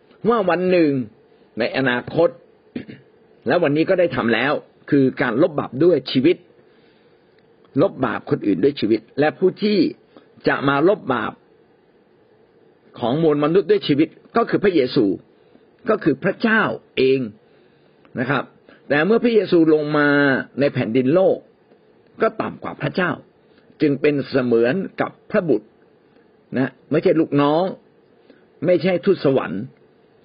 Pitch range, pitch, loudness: 135-215 Hz, 160 Hz, -19 LUFS